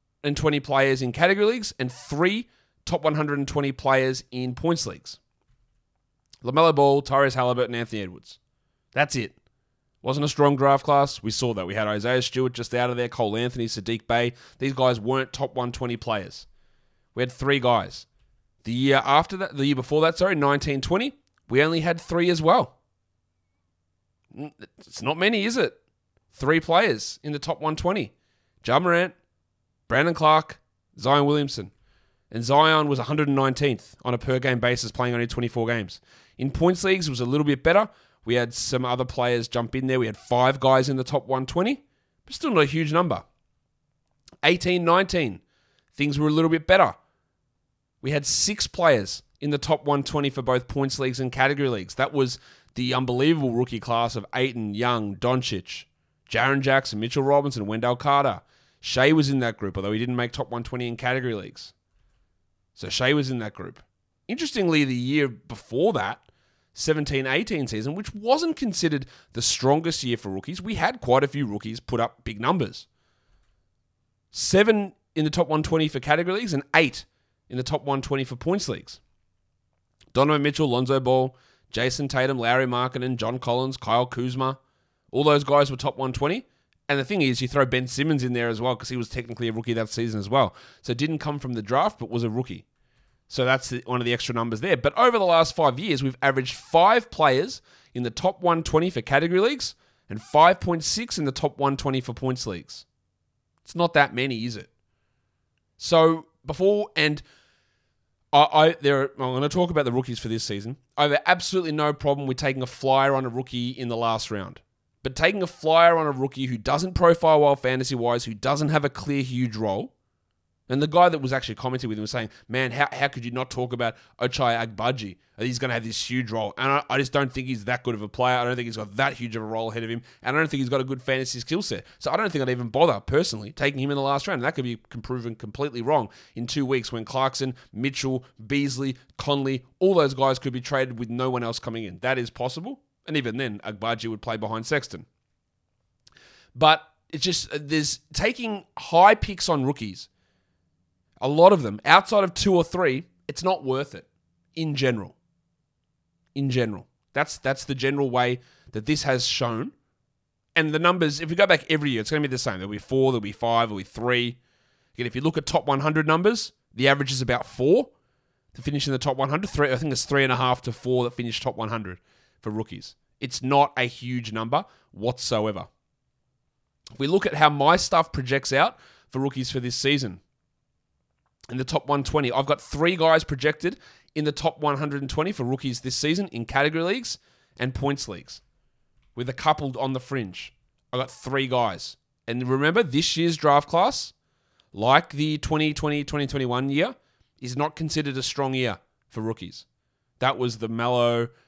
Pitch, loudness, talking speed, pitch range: 130 Hz, -24 LUFS, 200 wpm, 120-145 Hz